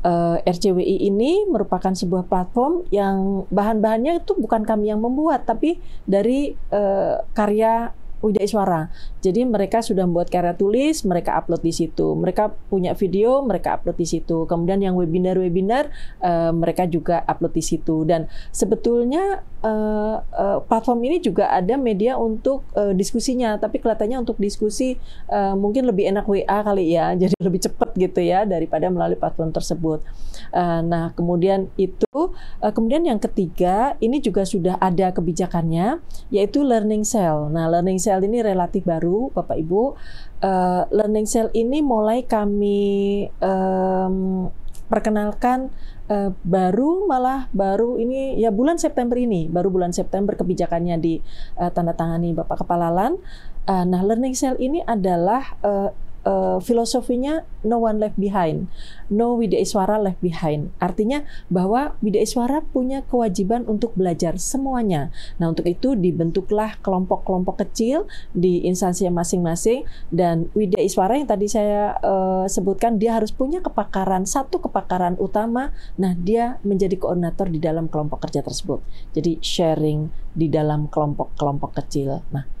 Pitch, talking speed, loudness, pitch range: 200 Hz, 140 wpm, -21 LUFS, 175-230 Hz